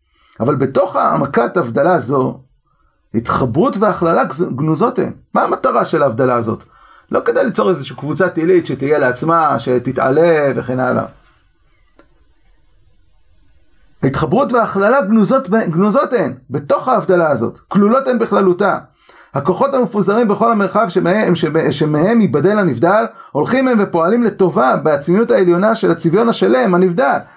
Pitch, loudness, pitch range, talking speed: 185 Hz, -14 LUFS, 150-220 Hz, 125 wpm